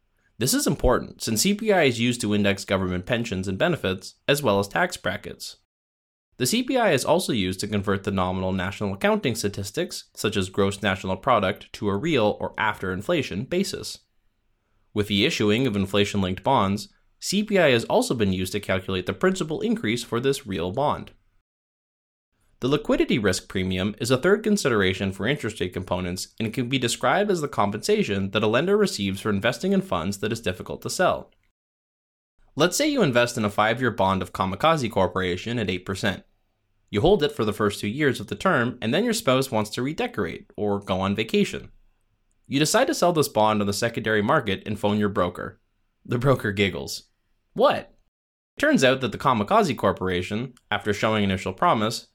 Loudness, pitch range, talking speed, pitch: -24 LUFS, 95-125 Hz, 180 wpm, 105 Hz